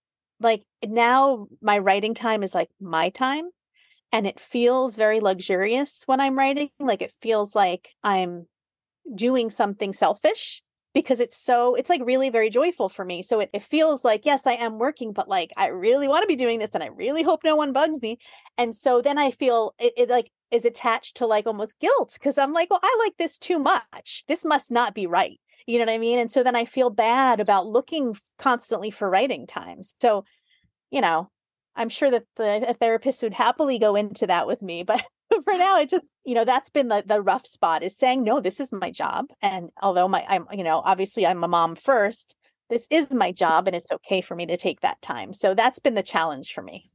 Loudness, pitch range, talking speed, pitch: -23 LUFS, 205-275 Hz, 220 wpm, 235 Hz